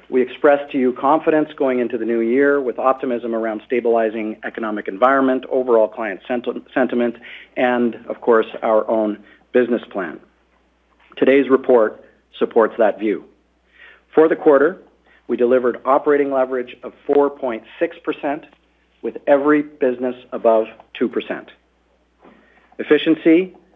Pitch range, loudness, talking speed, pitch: 115-140 Hz, -18 LUFS, 120 wpm, 125 Hz